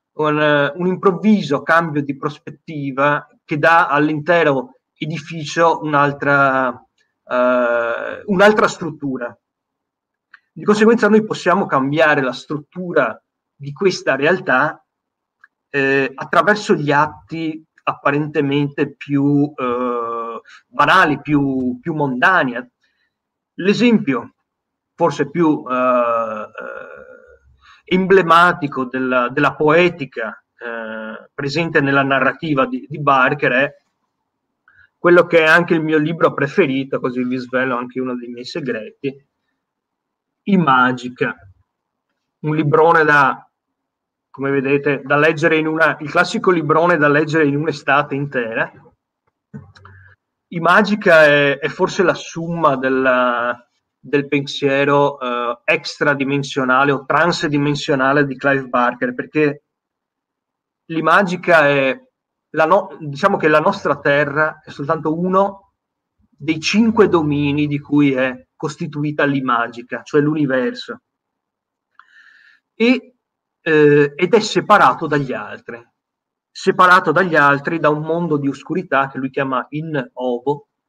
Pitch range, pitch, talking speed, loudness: 135-170 Hz, 150 Hz, 110 wpm, -16 LUFS